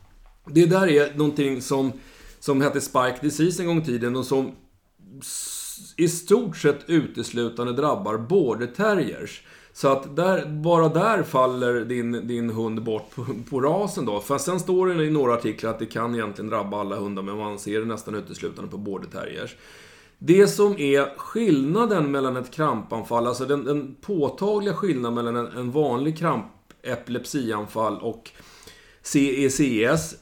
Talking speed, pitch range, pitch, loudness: 155 wpm, 120-160 Hz, 135 Hz, -24 LUFS